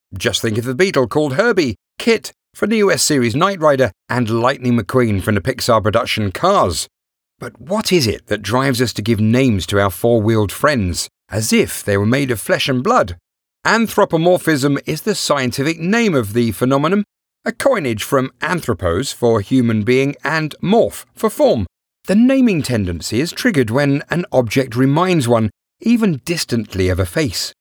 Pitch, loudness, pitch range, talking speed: 130 Hz, -16 LUFS, 115-170 Hz, 170 wpm